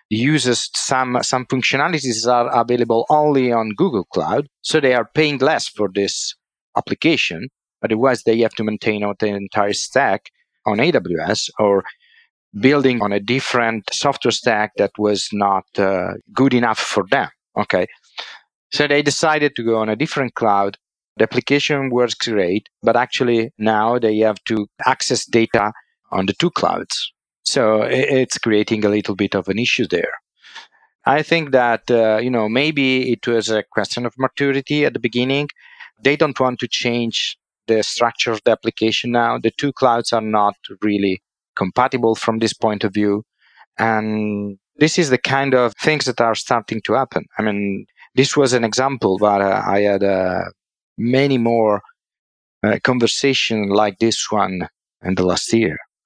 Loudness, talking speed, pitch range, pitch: -18 LUFS, 165 wpm, 105-130 Hz, 115 Hz